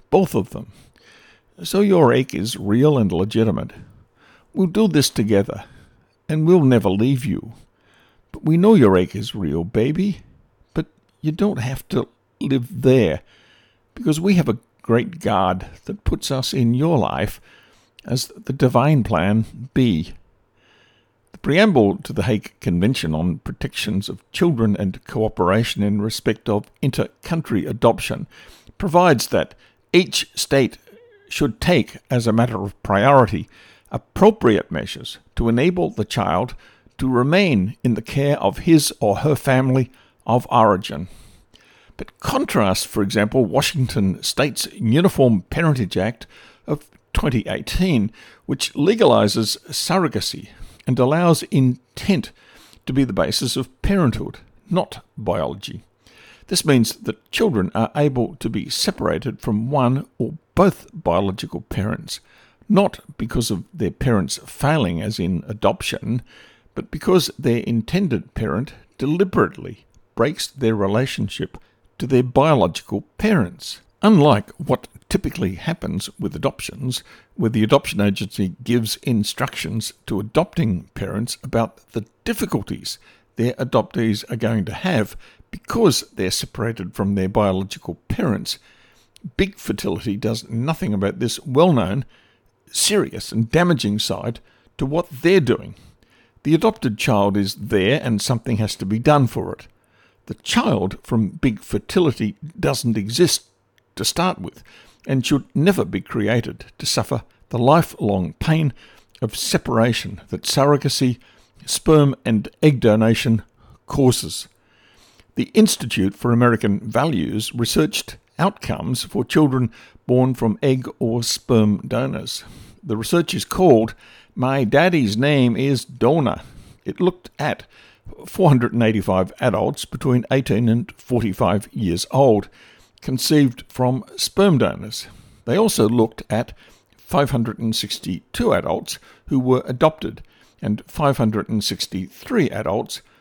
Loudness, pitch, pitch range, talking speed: -20 LUFS, 120 Hz, 105-140 Hz, 125 wpm